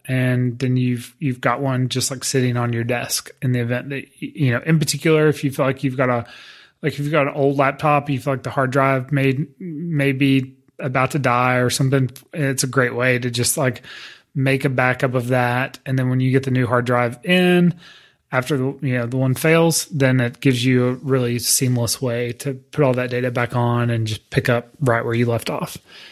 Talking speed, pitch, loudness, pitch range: 230 wpm, 130 Hz, -19 LUFS, 125-140 Hz